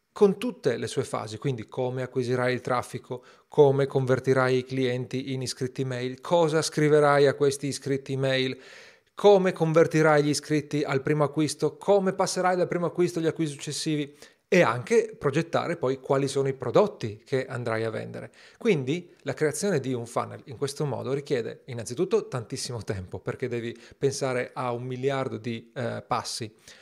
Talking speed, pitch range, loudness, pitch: 160 wpm, 125-155 Hz, -26 LUFS, 135 Hz